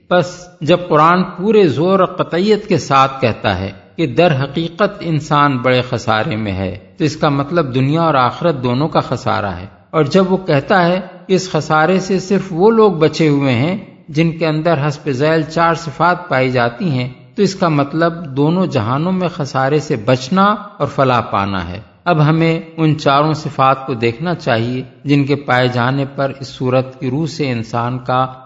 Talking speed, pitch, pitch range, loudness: 185 wpm, 150 Hz, 130-170 Hz, -15 LUFS